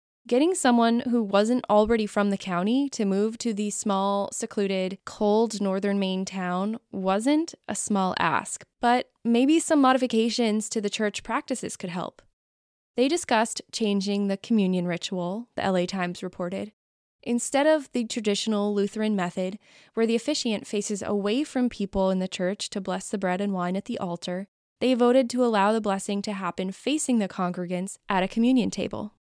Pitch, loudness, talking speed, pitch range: 210 Hz, -26 LUFS, 170 wpm, 190-240 Hz